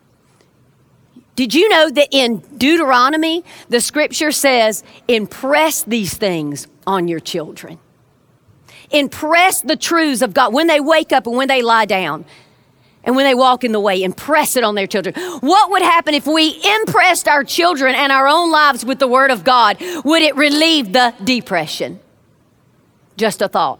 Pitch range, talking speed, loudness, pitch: 200-310 Hz, 165 wpm, -14 LUFS, 260 Hz